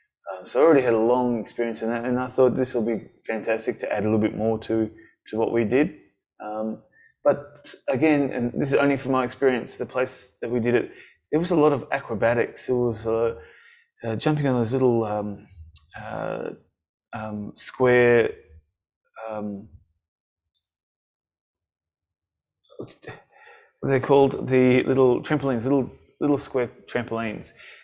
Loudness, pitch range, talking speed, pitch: -23 LUFS, 105-130 Hz, 155 wpm, 120 Hz